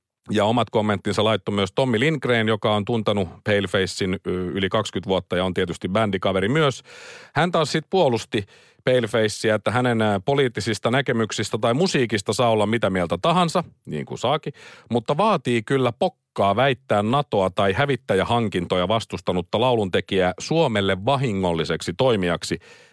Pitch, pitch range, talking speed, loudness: 110 Hz, 100-130 Hz, 135 wpm, -22 LUFS